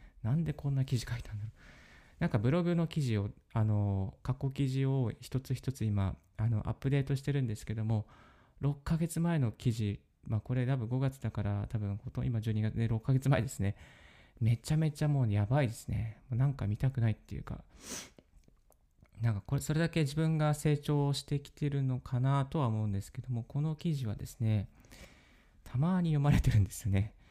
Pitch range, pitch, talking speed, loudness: 110-140 Hz, 125 Hz, 365 characters per minute, -34 LUFS